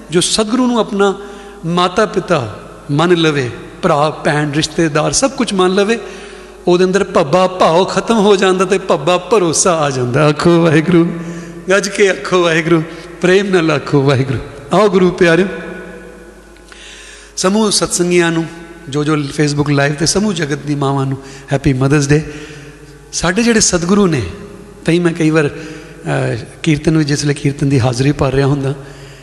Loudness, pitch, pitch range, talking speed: -13 LUFS, 165 Hz, 145-185 Hz, 150 wpm